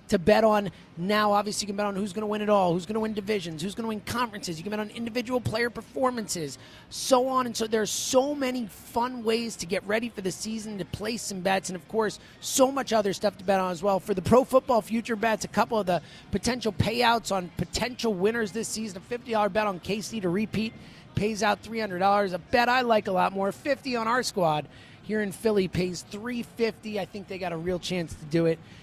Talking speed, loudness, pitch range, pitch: 250 wpm, -27 LUFS, 190-230 Hz, 210 Hz